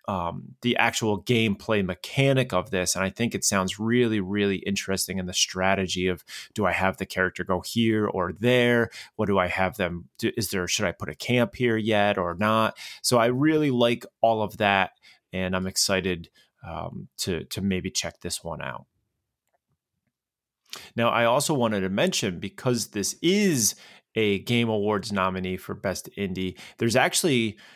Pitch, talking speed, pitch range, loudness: 100 Hz, 175 wpm, 95-115 Hz, -25 LUFS